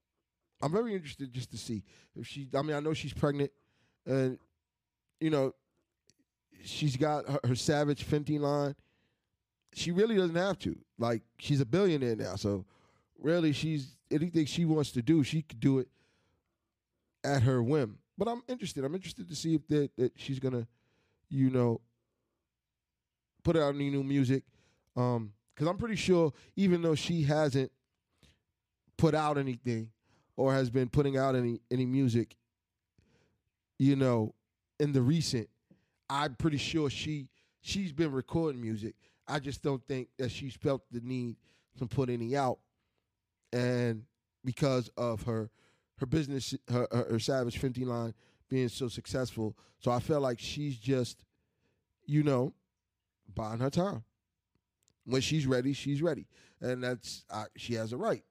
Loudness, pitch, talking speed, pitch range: -33 LUFS, 130 Hz, 155 wpm, 115-145 Hz